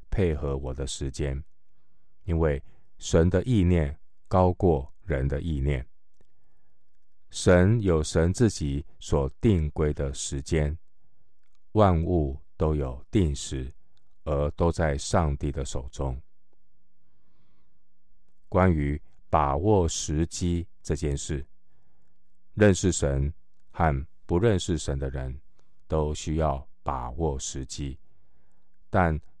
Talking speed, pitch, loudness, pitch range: 145 characters per minute, 75 Hz, -27 LUFS, 70-90 Hz